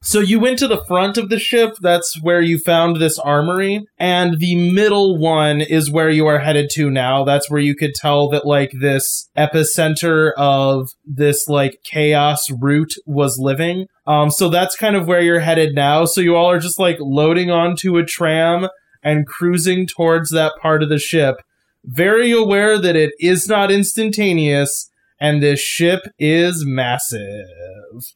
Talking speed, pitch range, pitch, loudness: 175 wpm, 145-180 Hz, 160 Hz, -15 LUFS